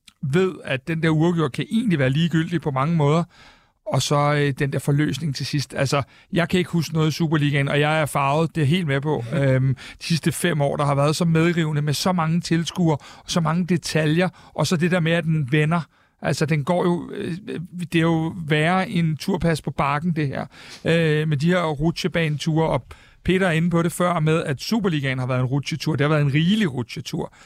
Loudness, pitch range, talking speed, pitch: -22 LUFS, 145-170 Hz, 225 wpm, 160 Hz